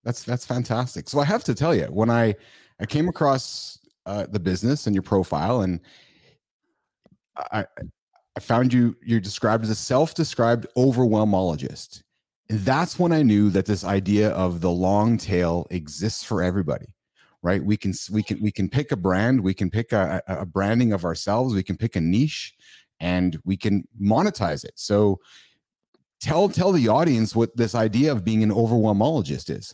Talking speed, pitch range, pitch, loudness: 175 wpm, 95-120 Hz, 110 Hz, -23 LUFS